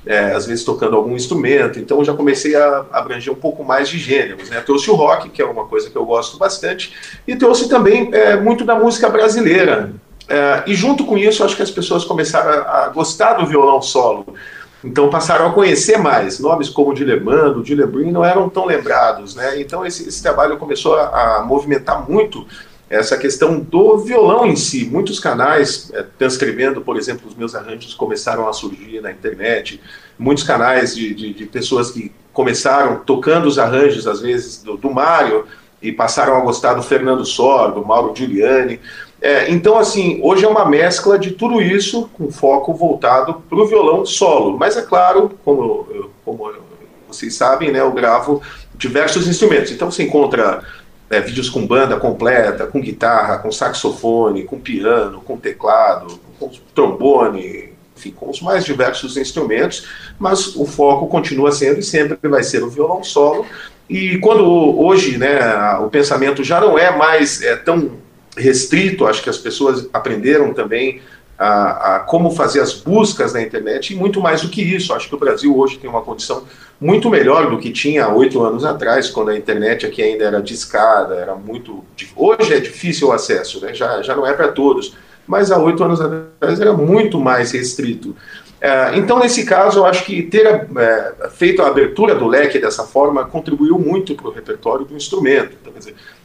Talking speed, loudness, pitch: 185 wpm, -14 LUFS, 180 Hz